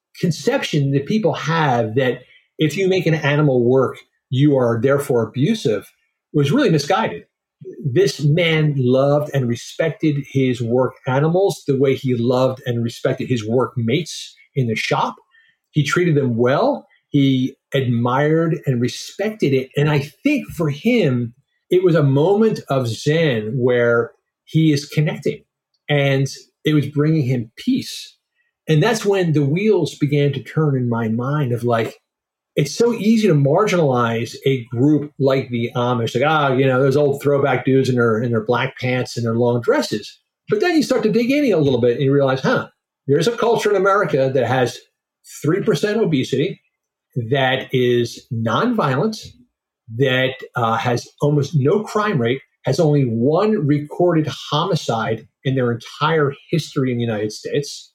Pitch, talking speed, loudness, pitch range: 140 Hz, 165 wpm, -18 LUFS, 125-160 Hz